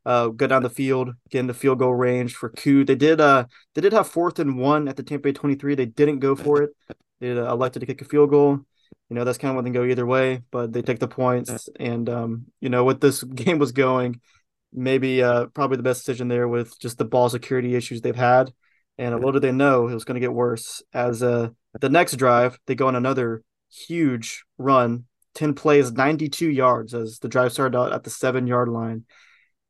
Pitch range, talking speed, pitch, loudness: 120-135 Hz, 235 wpm, 130 Hz, -21 LUFS